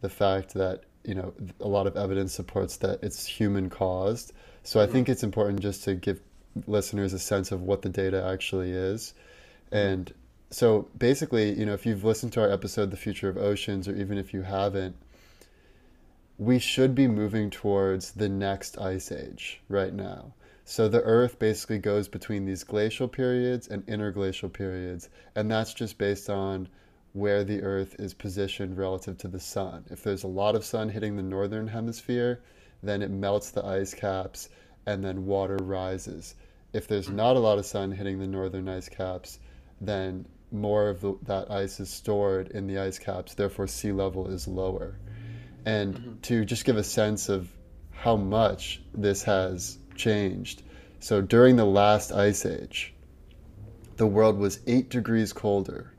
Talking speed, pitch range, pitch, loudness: 175 wpm, 95-105 Hz, 100 Hz, -28 LUFS